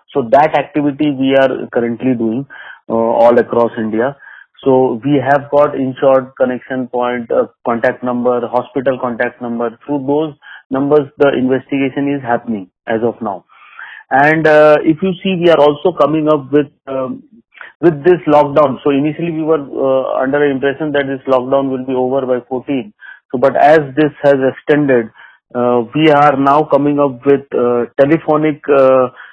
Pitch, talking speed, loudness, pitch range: 135 Hz, 165 wpm, -13 LUFS, 125-150 Hz